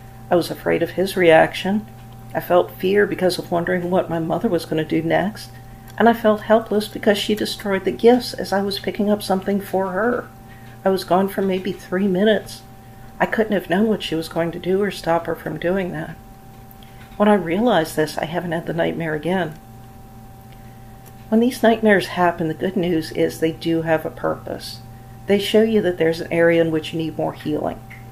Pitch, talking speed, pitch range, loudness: 170 Hz, 205 wpm, 130-195 Hz, -20 LUFS